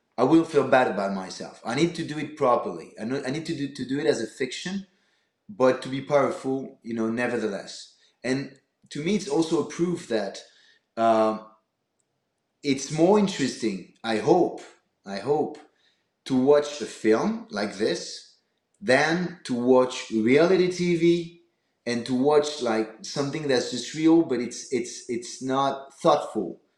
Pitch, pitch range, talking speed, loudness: 140 Hz, 120-165 Hz, 155 wpm, -25 LUFS